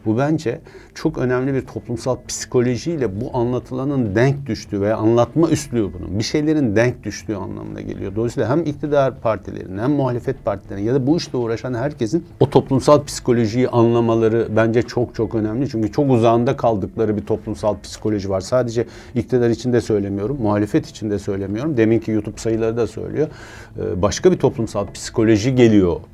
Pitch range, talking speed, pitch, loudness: 110-130 Hz, 155 wpm, 115 Hz, -19 LUFS